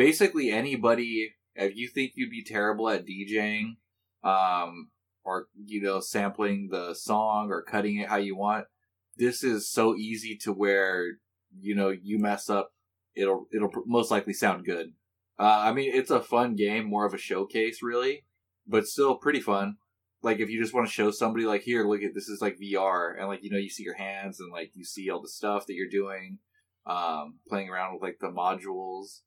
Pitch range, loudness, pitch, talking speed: 95-115 Hz, -29 LUFS, 105 Hz, 200 wpm